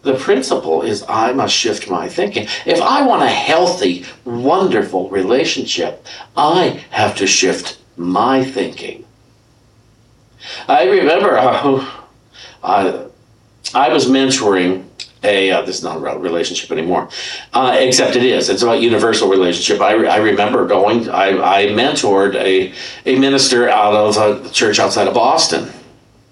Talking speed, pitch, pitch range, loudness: 140 wpm, 120 Hz, 95-130 Hz, -14 LUFS